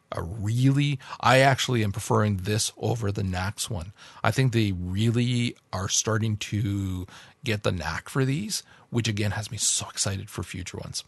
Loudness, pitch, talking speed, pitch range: -26 LUFS, 110 Hz, 175 wpm, 100-120 Hz